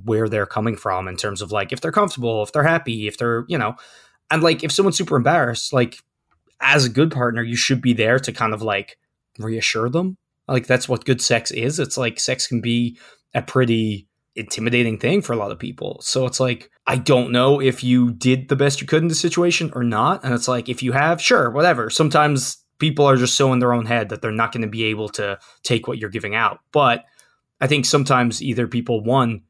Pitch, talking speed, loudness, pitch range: 125 Hz, 230 wpm, -19 LUFS, 115-140 Hz